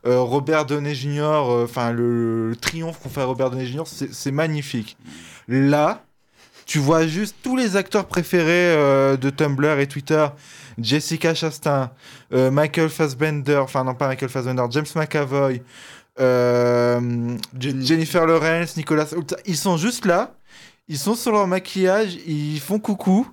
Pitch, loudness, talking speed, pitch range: 150 Hz, -21 LUFS, 150 wpm, 130-165 Hz